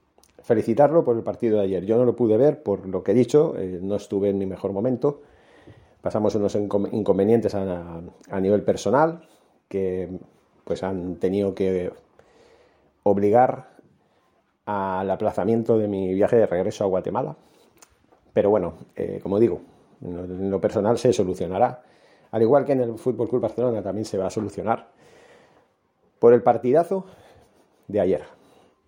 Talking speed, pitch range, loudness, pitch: 150 wpm, 95-125 Hz, -23 LUFS, 105 Hz